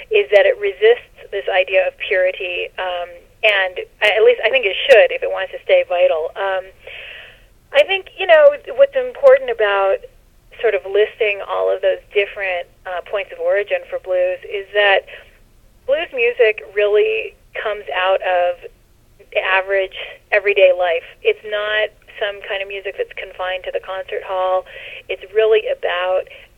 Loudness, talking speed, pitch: -17 LUFS, 155 wpm, 215 Hz